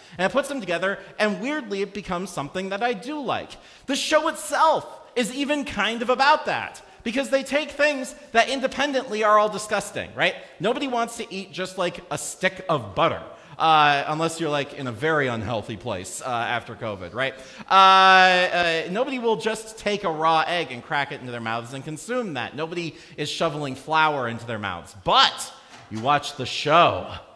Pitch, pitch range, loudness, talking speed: 185 Hz, 150-235 Hz, -23 LUFS, 190 wpm